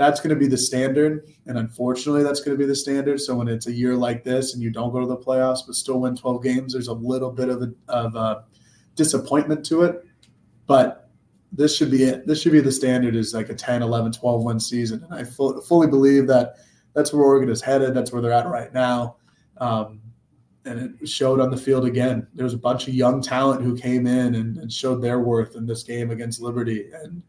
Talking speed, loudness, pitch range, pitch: 235 wpm, -21 LUFS, 120-135 Hz, 125 Hz